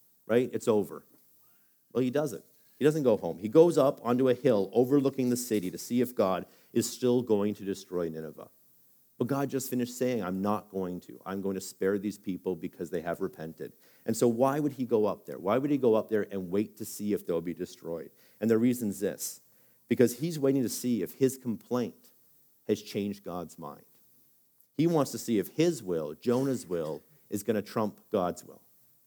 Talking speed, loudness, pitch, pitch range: 210 wpm, -30 LUFS, 110 Hz, 95-125 Hz